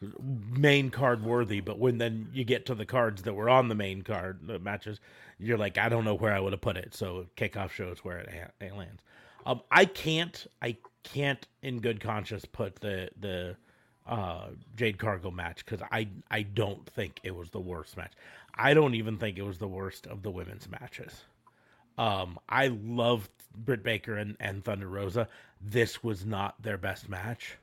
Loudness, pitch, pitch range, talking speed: -31 LUFS, 105 Hz, 95-120 Hz, 195 wpm